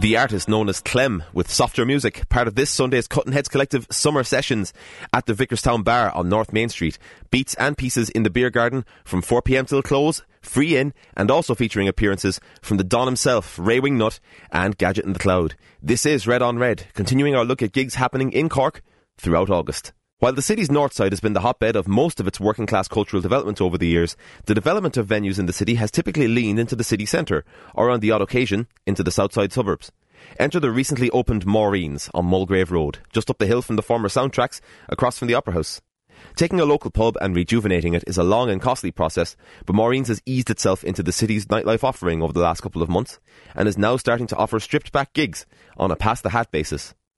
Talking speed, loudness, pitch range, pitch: 225 wpm, -21 LUFS, 95-125 Hz, 110 Hz